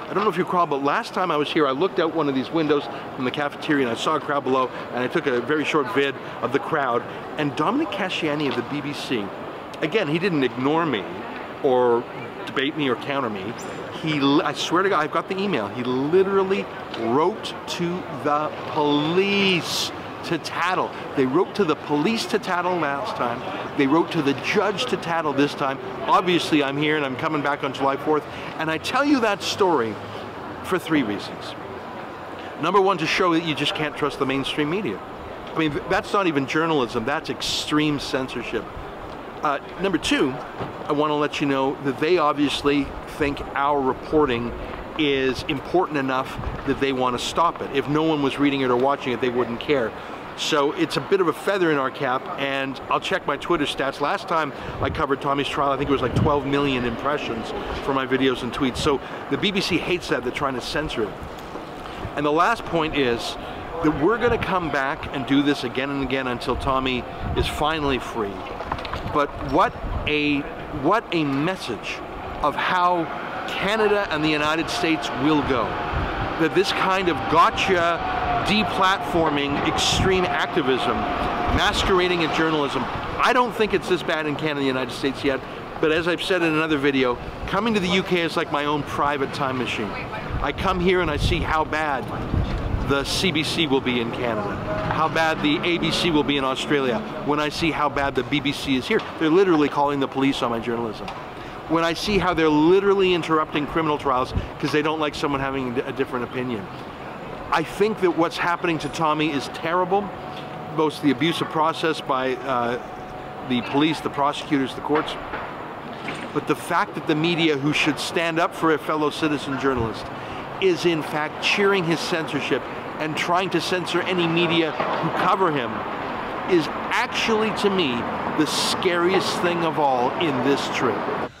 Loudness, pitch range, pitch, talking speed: -22 LUFS, 135-165 Hz, 150 Hz, 185 wpm